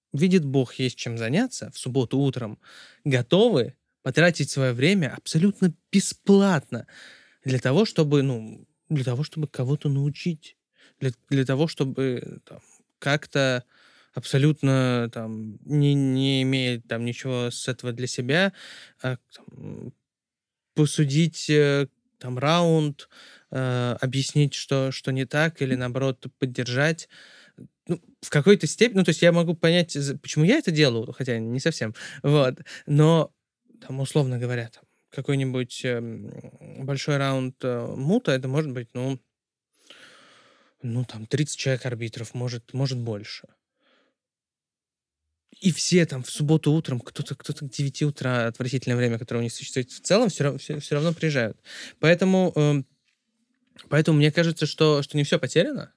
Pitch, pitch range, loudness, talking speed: 140 Hz, 125-160 Hz, -24 LUFS, 130 wpm